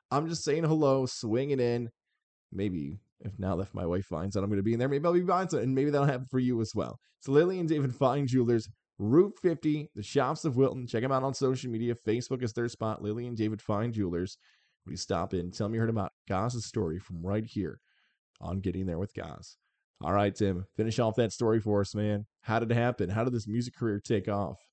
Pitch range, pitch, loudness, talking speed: 100-130 Hz, 115 Hz, -30 LUFS, 240 wpm